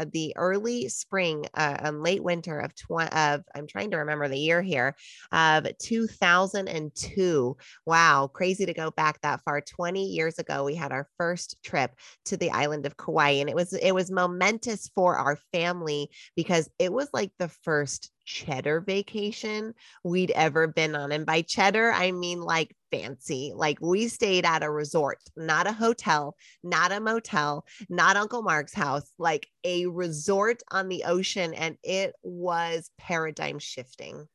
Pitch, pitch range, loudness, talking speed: 170 Hz, 150-185 Hz, -27 LUFS, 165 wpm